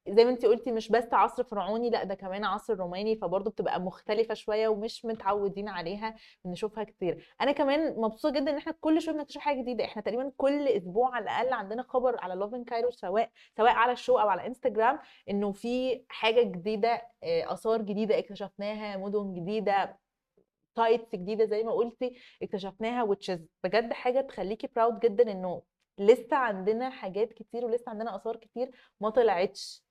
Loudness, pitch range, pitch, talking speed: -30 LUFS, 205-245 Hz, 225 Hz, 170 wpm